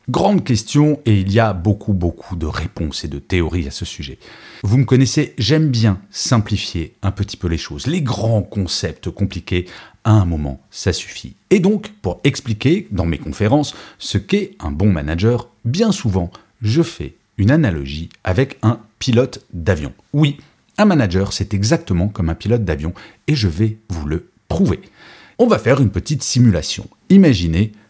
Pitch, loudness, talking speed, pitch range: 105 Hz, -18 LUFS, 170 wpm, 90-130 Hz